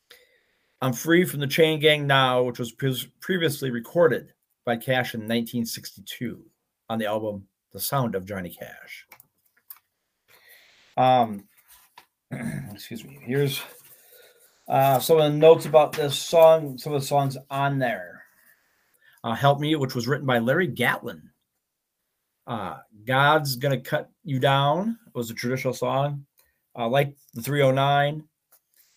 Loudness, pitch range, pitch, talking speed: -23 LUFS, 125-150 Hz, 140 Hz, 135 wpm